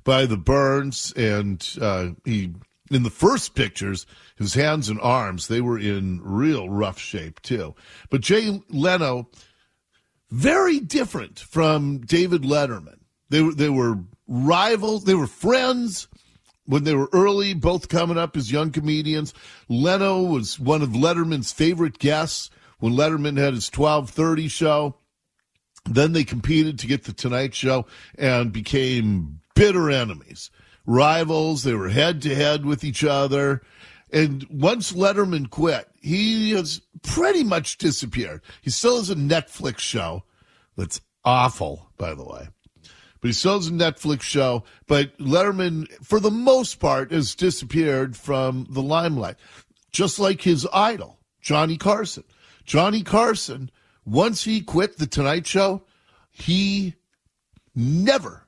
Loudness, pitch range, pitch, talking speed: -22 LUFS, 120-170 Hz, 145 Hz, 140 wpm